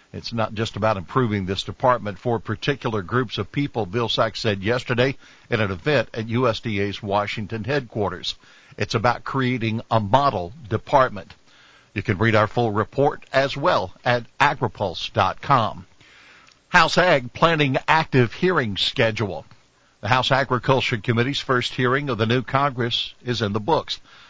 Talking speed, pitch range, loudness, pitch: 145 wpm, 110-130 Hz, -22 LUFS, 120 Hz